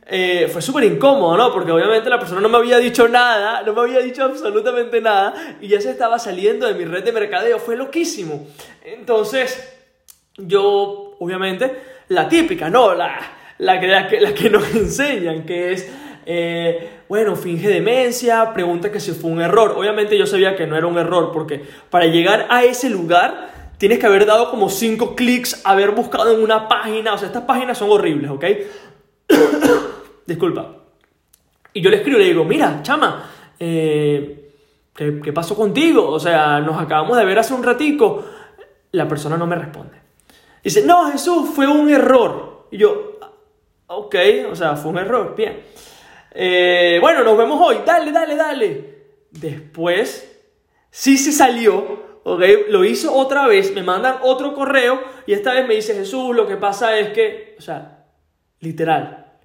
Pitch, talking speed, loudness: 240 Hz, 170 wpm, -16 LUFS